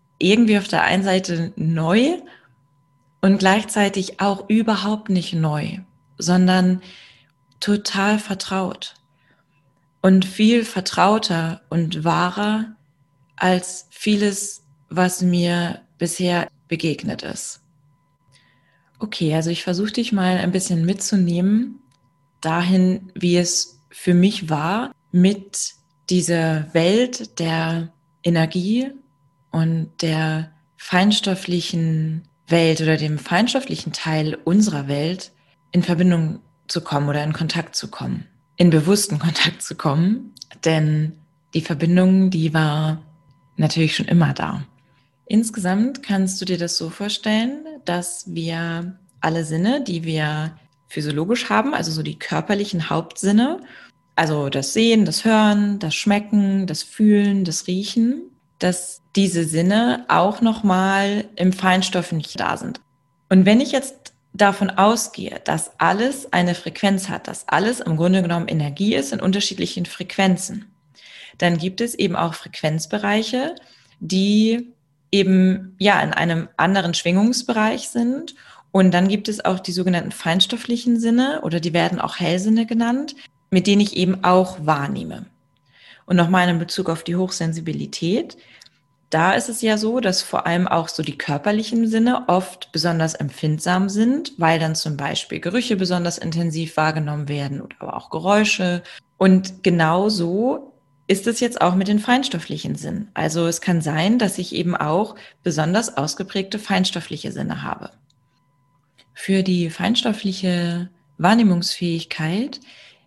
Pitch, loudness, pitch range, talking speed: 180 Hz, -20 LUFS, 160-205 Hz, 130 wpm